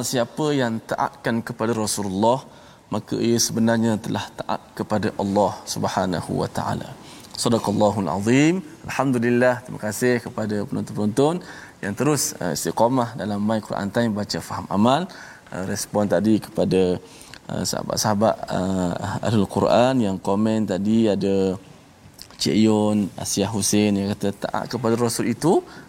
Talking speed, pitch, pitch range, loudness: 120 wpm, 105 Hz, 100-120 Hz, -22 LUFS